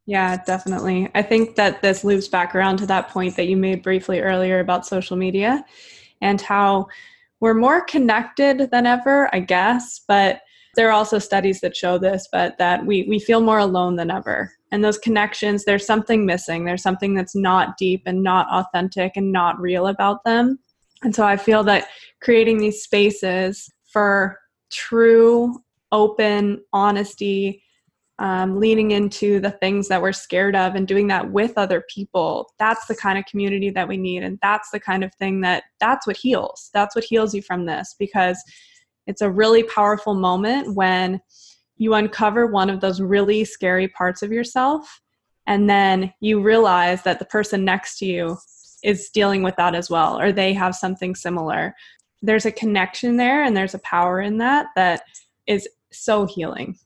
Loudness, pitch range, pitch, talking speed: -19 LUFS, 185-215 Hz, 200 Hz, 175 wpm